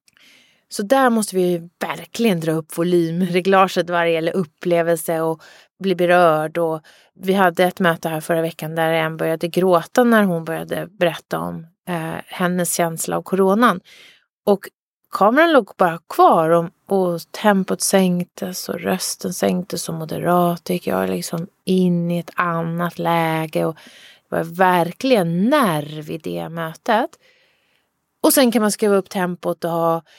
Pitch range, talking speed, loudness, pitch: 165-190 Hz, 150 wpm, -19 LUFS, 175 Hz